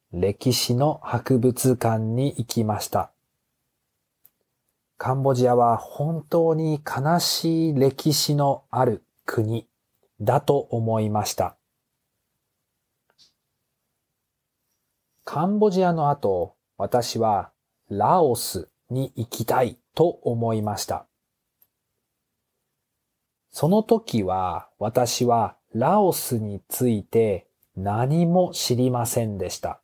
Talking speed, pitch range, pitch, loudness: 165 characters per minute, 115-150 Hz, 125 Hz, -23 LUFS